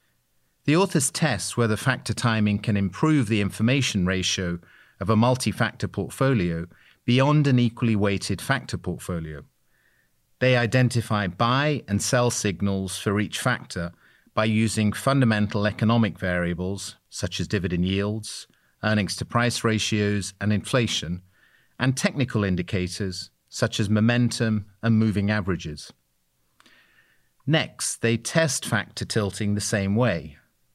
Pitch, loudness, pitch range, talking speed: 105 Hz, -24 LUFS, 95-120 Hz, 125 wpm